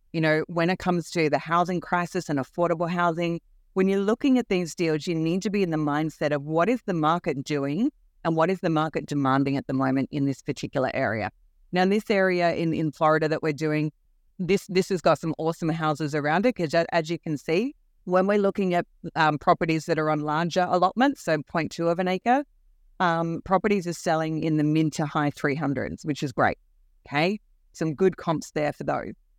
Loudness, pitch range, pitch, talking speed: -25 LUFS, 155-180 Hz, 165 Hz, 210 wpm